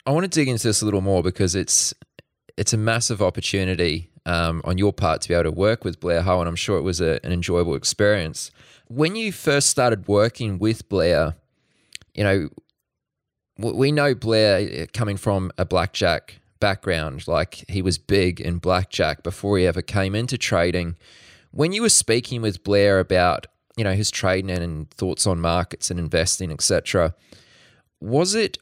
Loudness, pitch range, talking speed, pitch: -21 LUFS, 90-115 Hz, 180 wpm, 95 Hz